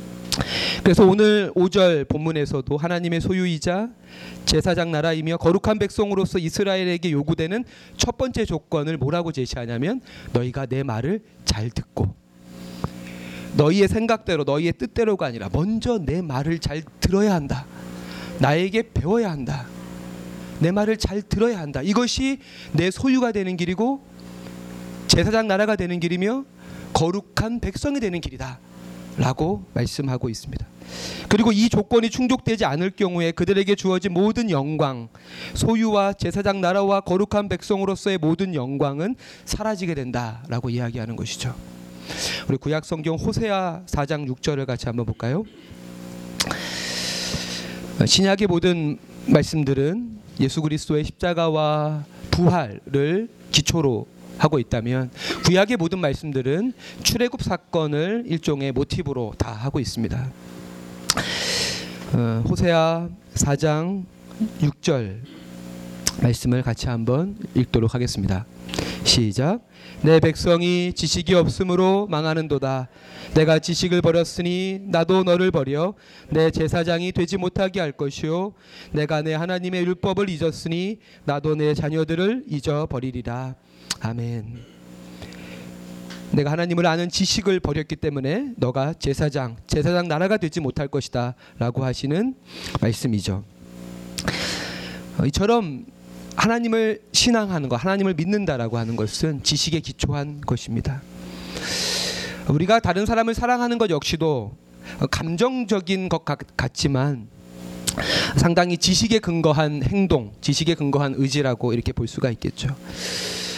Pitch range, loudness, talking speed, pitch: 120-185 Hz, -22 LUFS, 280 characters per minute, 155 Hz